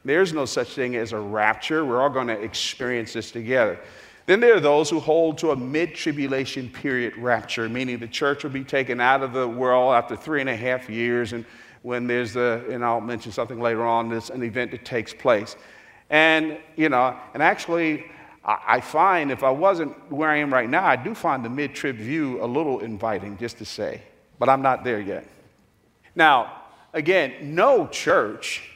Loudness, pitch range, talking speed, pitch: -22 LUFS, 120-145 Hz, 195 wpm, 125 Hz